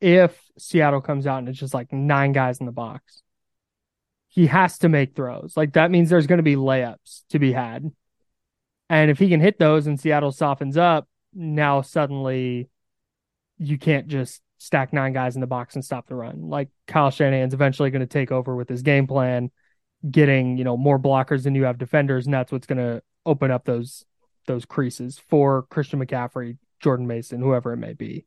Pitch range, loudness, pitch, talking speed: 125-150 Hz, -21 LUFS, 135 Hz, 200 wpm